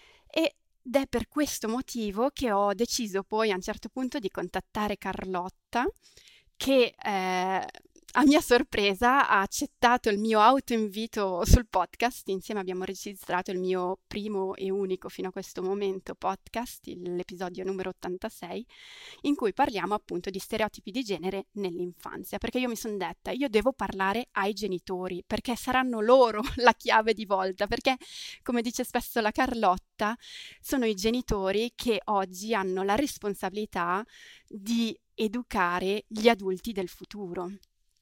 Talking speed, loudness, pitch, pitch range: 145 wpm, -28 LUFS, 210 Hz, 190-245 Hz